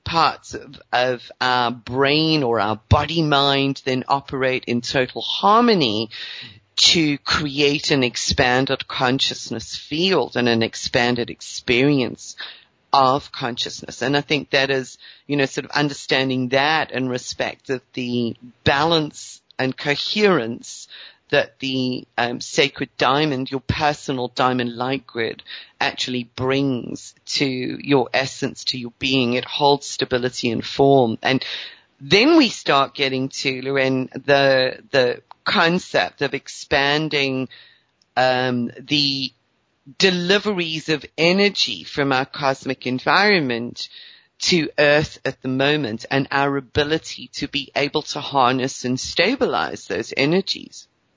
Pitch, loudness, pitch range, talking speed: 135 Hz, -20 LUFS, 125-145 Hz, 125 wpm